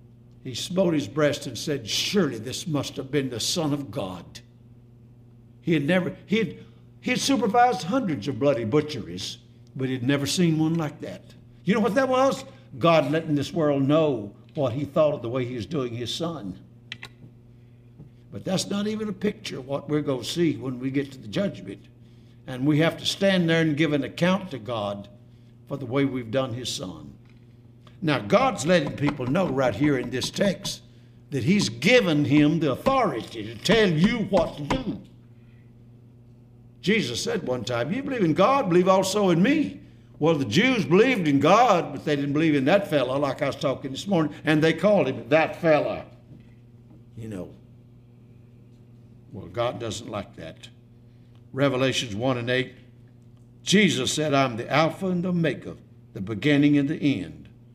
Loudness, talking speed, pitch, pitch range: -24 LUFS, 180 wpm, 135 Hz, 120-160 Hz